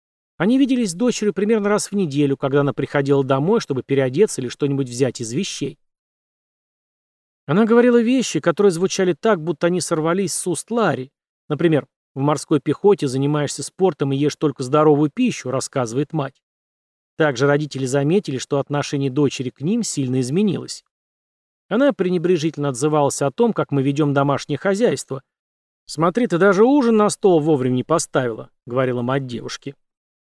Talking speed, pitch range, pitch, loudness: 150 wpm, 140-190 Hz, 150 Hz, -19 LUFS